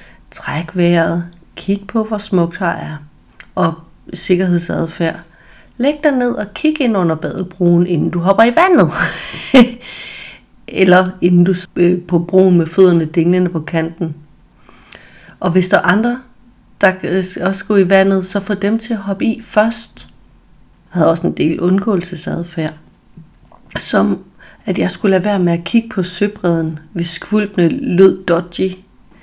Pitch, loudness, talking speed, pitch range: 185 Hz, -14 LUFS, 150 wpm, 170-210 Hz